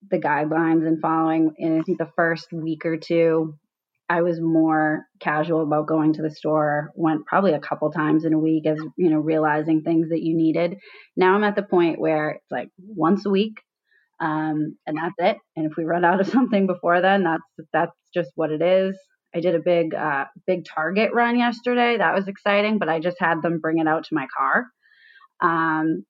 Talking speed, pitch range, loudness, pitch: 205 wpm, 155-185 Hz, -22 LUFS, 165 Hz